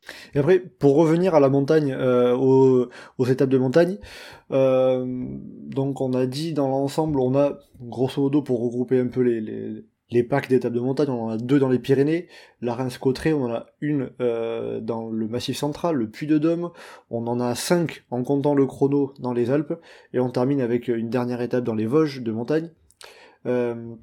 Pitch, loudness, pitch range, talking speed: 130 Hz, -22 LUFS, 120-145 Hz, 195 wpm